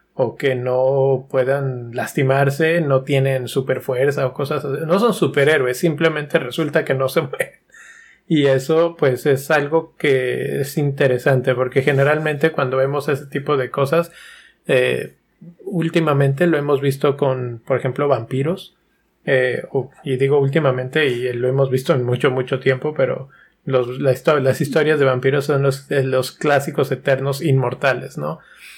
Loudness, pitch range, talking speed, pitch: -18 LUFS, 130-150 Hz, 155 wpm, 140 Hz